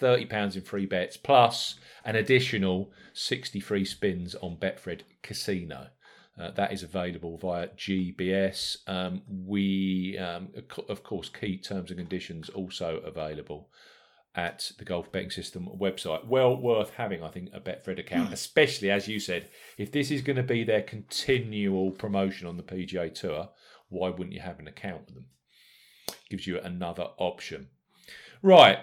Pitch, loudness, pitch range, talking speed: 95 Hz, -29 LUFS, 90-105 Hz, 160 wpm